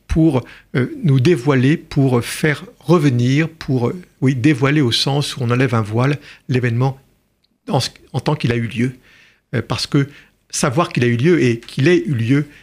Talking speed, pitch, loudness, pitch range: 170 wpm, 135 Hz, -17 LUFS, 125-155 Hz